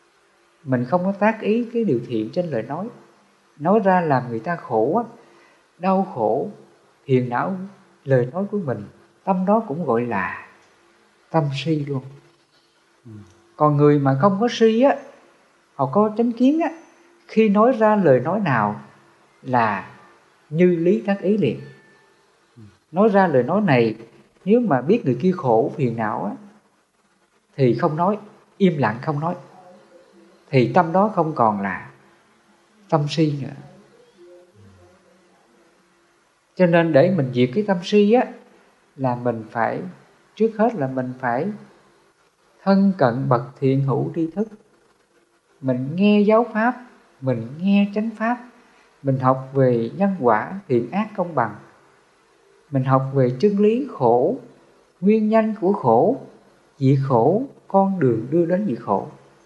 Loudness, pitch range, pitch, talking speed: -20 LUFS, 130-210 Hz, 175 Hz, 145 wpm